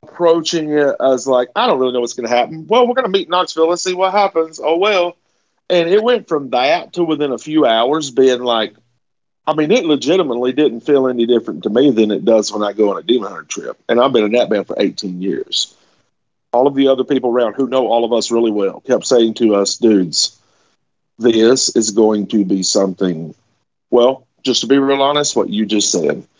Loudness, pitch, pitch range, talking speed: -15 LUFS, 130 Hz, 115-155 Hz, 225 wpm